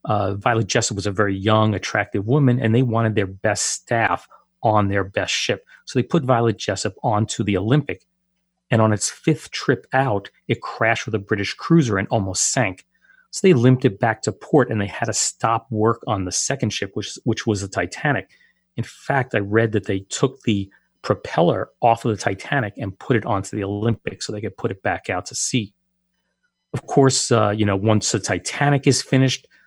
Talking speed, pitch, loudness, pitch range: 205 wpm, 115 Hz, -20 LUFS, 105-130 Hz